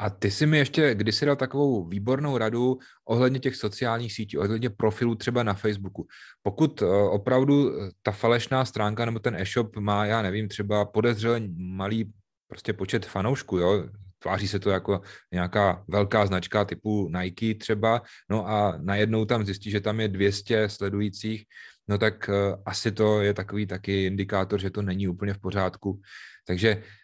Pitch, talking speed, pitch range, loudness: 105 Hz, 160 wpm, 100-115 Hz, -26 LUFS